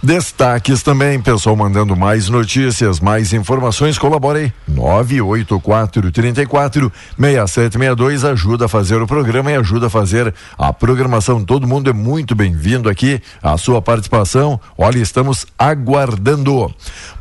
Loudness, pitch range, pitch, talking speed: -14 LUFS, 105-135 Hz, 120 Hz, 115 wpm